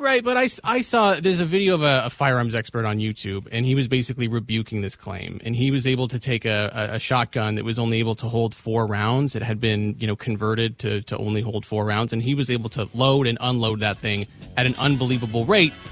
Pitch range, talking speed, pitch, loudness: 110-130 Hz, 245 wpm, 115 Hz, -22 LUFS